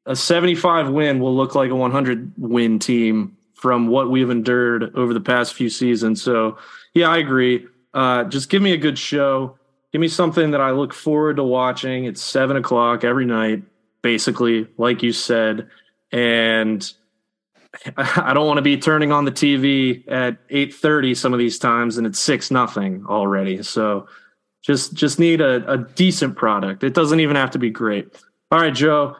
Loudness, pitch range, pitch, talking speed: -18 LUFS, 115-145 Hz, 130 Hz, 180 wpm